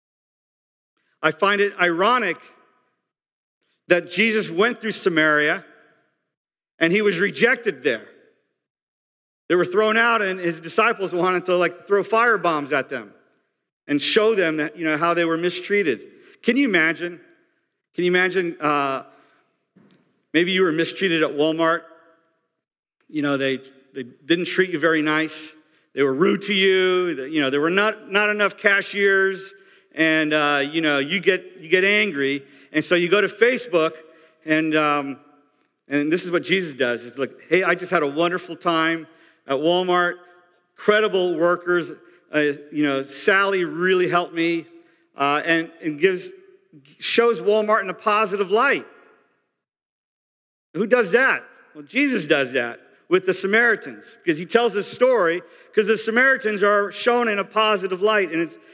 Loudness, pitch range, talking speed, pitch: -20 LUFS, 160-210 Hz, 155 wpm, 180 Hz